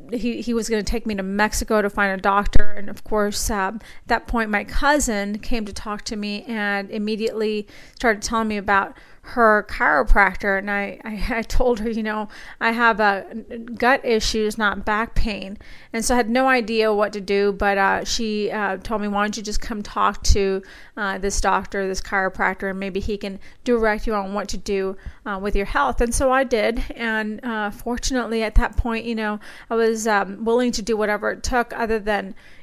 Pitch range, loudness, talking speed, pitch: 205-230 Hz, -22 LUFS, 210 wpm, 215 Hz